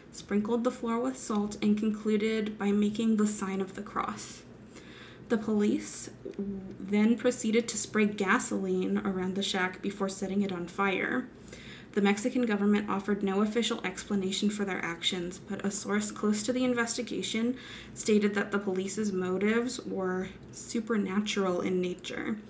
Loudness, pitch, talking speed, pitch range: -30 LUFS, 205 Hz, 145 wpm, 195-220 Hz